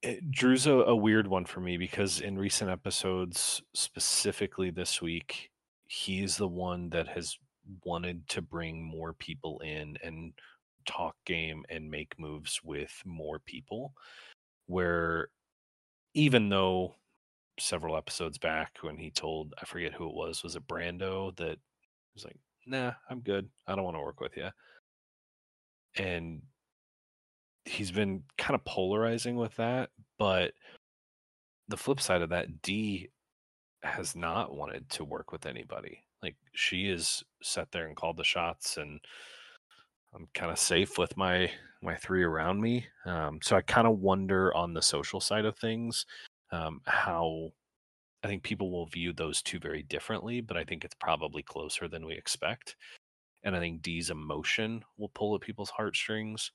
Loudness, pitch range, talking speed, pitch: -33 LUFS, 85-110 Hz, 160 wpm, 95 Hz